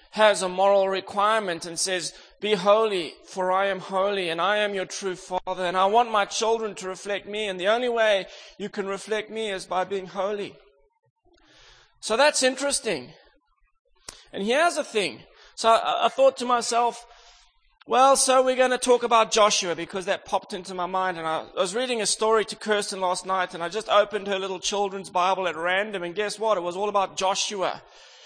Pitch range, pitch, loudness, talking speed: 190-230 Hz, 205 Hz, -24 LUFS, 200 wpm